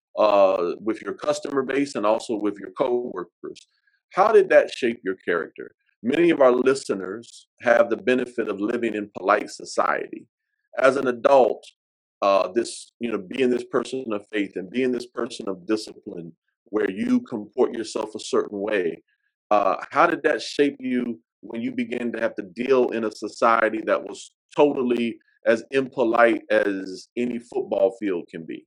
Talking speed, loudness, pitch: 165 wpm, -23 LUFS, 125 Hz